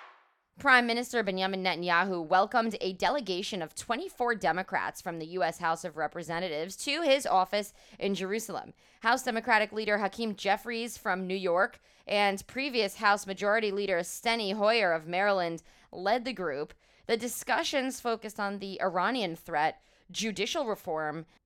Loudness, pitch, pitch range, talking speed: -30 LUFS, 200 Hz, 185-230 Hz, 140 wpm